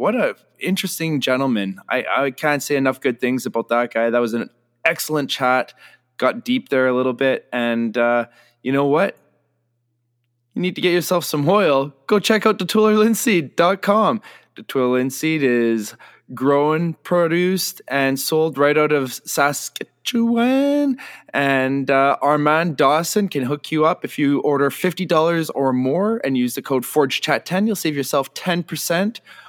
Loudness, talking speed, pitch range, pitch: -19 LUFS, 160 wpm, 130-175 Hz, 145 Hz